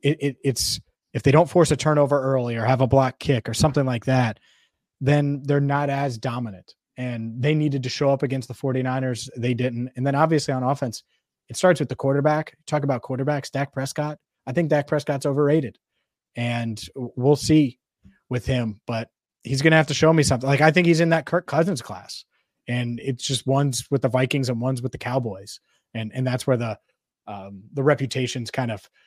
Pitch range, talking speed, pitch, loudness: 125-145 Hz, 205 wpm, 135 Hz, -22 LUFS